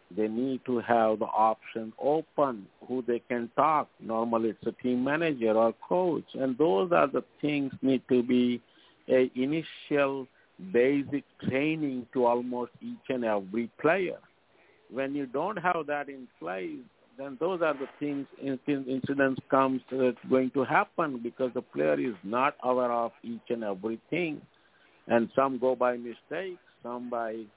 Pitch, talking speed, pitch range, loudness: 130 Hz, 155 wpm, 120-140 Hz, -29 LUFS